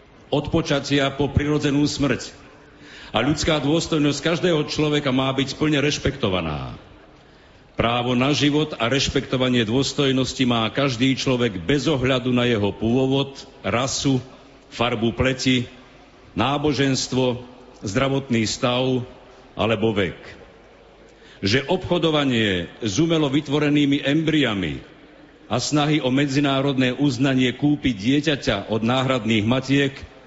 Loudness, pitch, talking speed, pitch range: -21 LUFS, 135 Hz, 105 wpm, 125-145 Hz